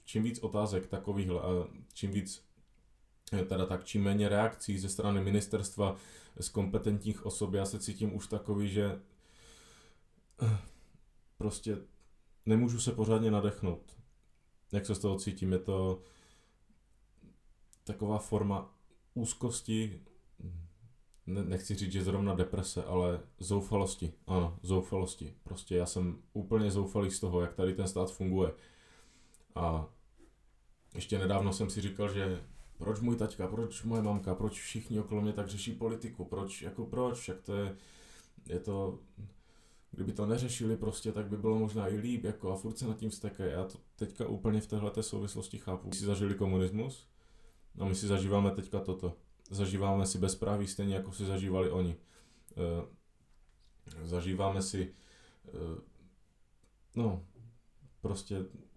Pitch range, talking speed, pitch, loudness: 95-105 Hz, 140 wpm, 100 Hz, -35 LUFS